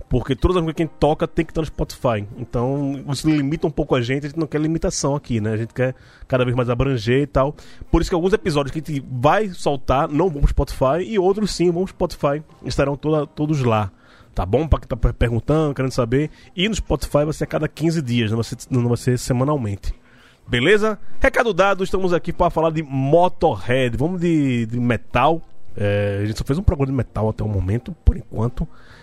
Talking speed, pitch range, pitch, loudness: 225 wpm, 125-165 Hz, 140 Hz, -20 LUFS